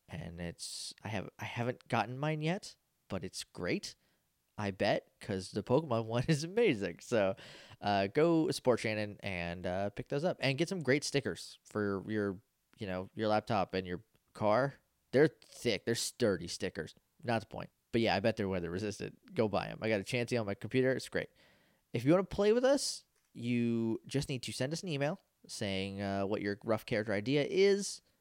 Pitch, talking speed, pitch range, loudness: 115 Hz, 200 wpm, 100-140 Hz, -35 LUFS